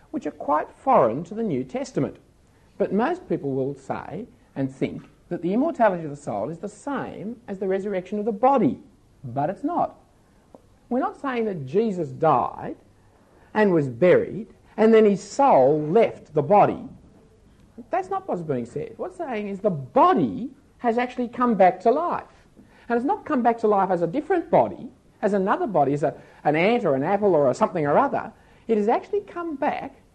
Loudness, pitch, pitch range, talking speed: -23 LUFS, 215 Hz, 180-255 Hz, 190 wpm